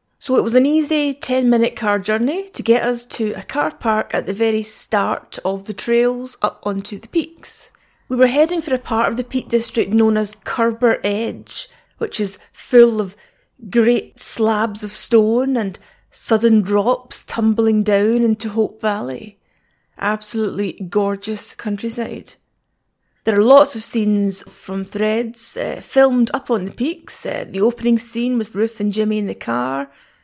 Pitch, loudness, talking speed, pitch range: 225 Hz, -18 LUFS, 165 wpm, 210-240 Hz